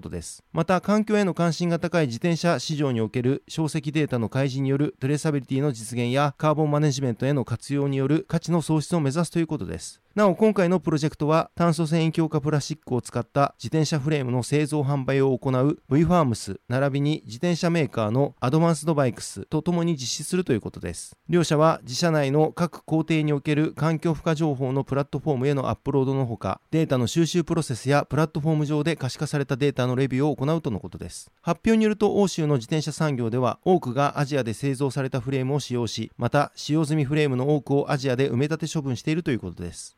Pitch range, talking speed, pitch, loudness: 130-160 Hz, 480 characters per minute, 145 Hz, -24 LUFS